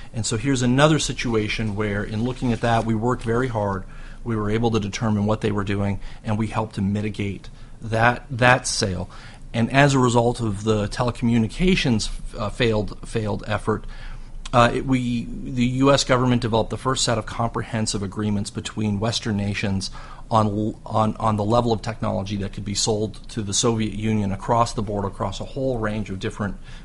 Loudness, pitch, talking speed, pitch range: -22 LUFS, 110 Hz, 185 wpm, 105-120 Hz